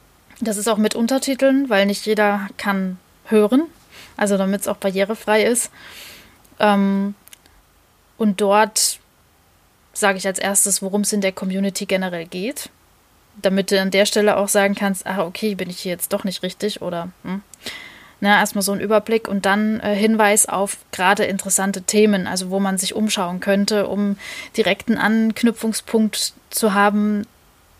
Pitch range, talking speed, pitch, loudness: 195-215 Hz, 155 wpm, 200 Hz, -19 LUFS